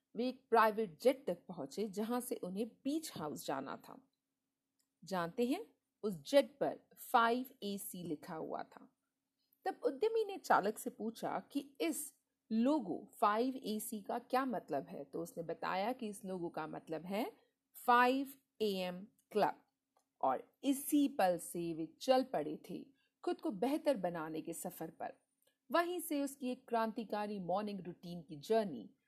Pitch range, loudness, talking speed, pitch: 185-270 Hz, -38 LUFS, 155 wpm, 230 Hz